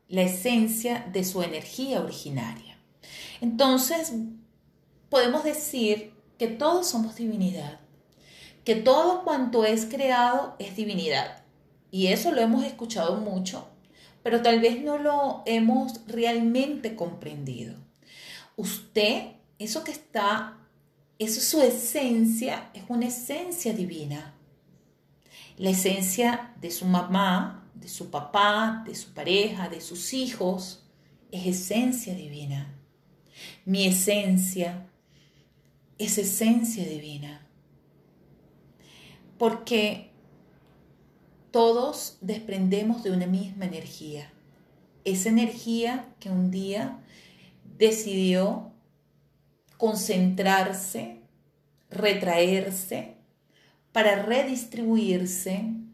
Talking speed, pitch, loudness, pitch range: 90 wpm, 210 Hz, -26 LUFS, 185-235 Hz